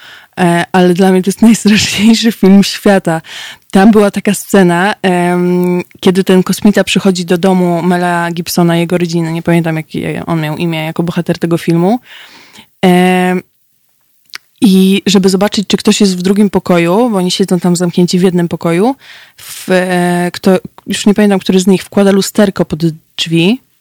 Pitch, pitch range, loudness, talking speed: 185 Hz, 175-200 Hz, -10 LUFS, 155 wpm